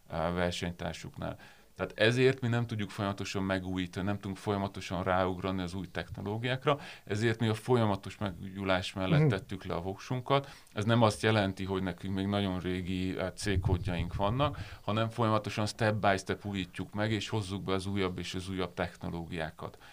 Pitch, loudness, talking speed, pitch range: 100 Hz, -33 LUFS, 155 wpm, 95-110 Hz